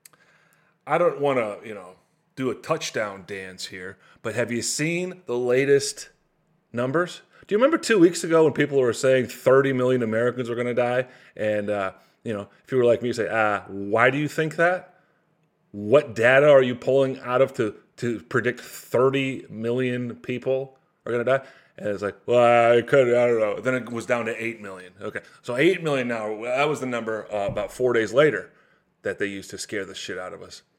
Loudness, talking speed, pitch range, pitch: -23 LUFS, 210 wpm, 115-140 Hz, 125 Hz